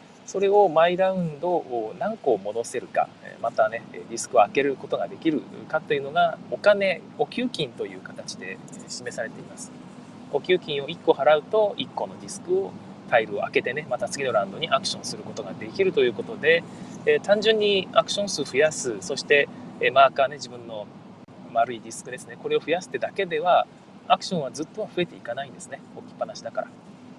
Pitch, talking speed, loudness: 205 Hz, 400 characters per minute, -24 LUFS